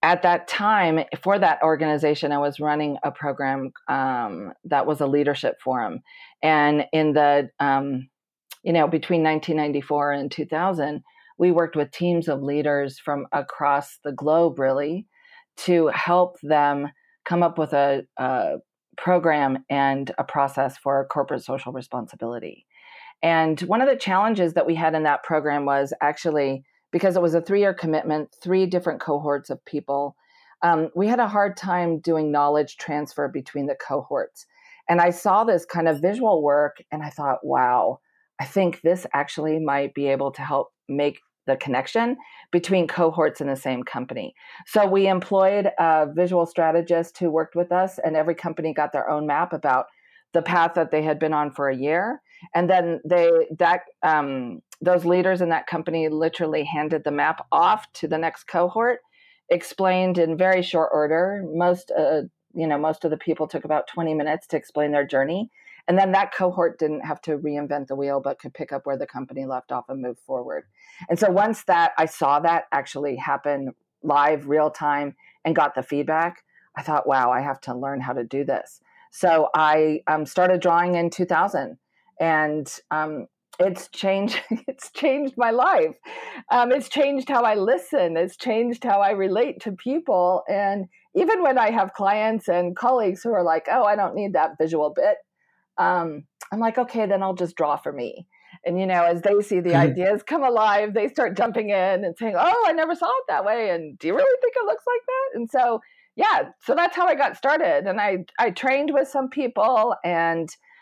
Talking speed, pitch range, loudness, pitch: 185 wpm, 145-200 Hz, -22 LUFS, 165 Hz